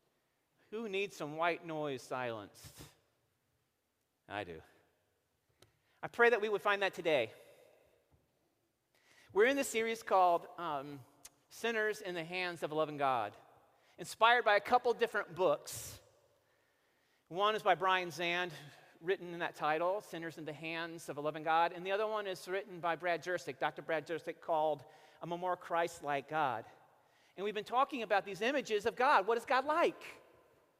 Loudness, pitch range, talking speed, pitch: -35 LUFS, 160-225 Hz, 165 wpm, 180 Hz